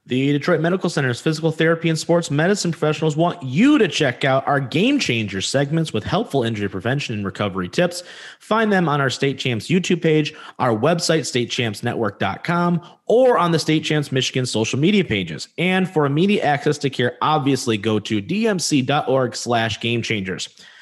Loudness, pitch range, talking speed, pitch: -19 LUFS, 120-170 Hz, 160 wpm, 145 Hz